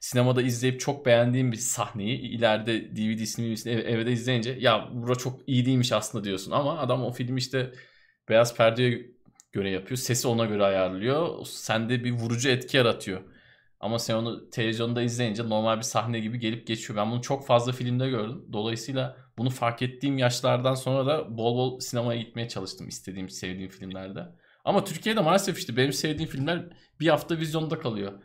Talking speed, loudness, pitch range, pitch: 170 wpm, -27 LUFS, 115-130 Hz, 120 Hz